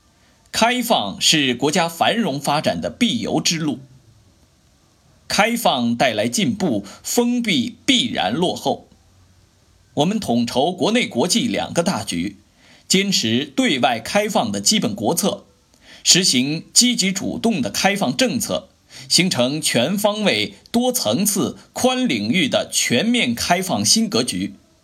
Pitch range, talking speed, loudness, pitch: 145-235 Hz, 190 characters per minute, -18 LUFS, 205 Hz